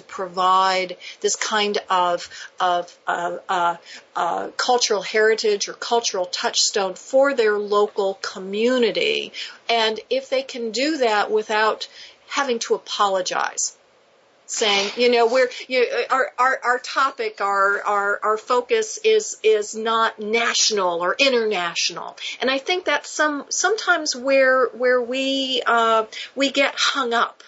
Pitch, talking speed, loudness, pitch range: 235 Hz, 130 wpm, -20 LUFS, 205-275 Hz